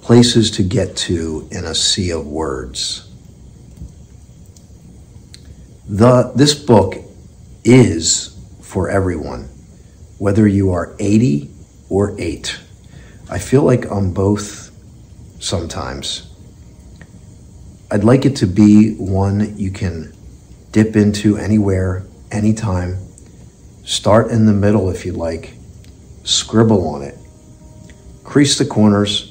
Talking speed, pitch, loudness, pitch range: 105 wpm, 100 Hz, -15 LUFS, 90-110 Hz